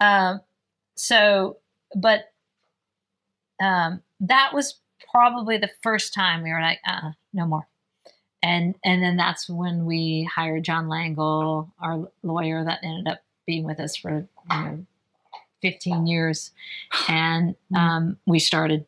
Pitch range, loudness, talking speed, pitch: 160-195 Hz, -23 LUFS, 135 wpm, 170 Hz